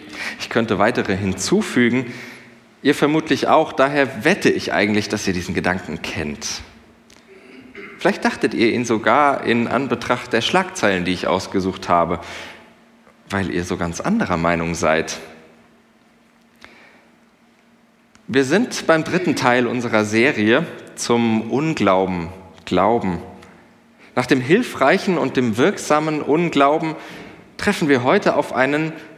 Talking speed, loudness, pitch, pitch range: 120 wpm, -19 LUFS, 115 Hz, 95-140 Hz